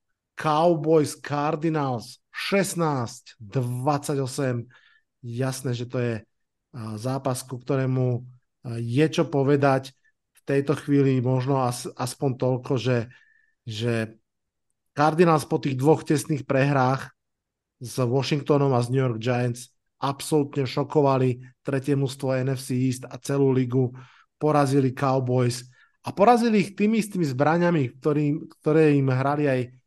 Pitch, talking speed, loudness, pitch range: 135 Hz, 115 wpm, -24 LUFS, 125-150 Hz